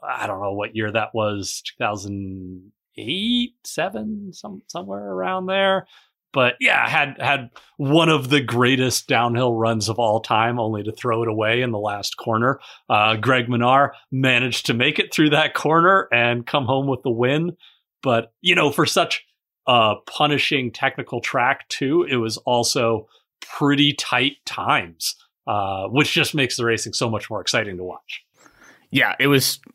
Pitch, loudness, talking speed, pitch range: 125 Hz, -20 LUFS, 170 wpm, 110-150 Hz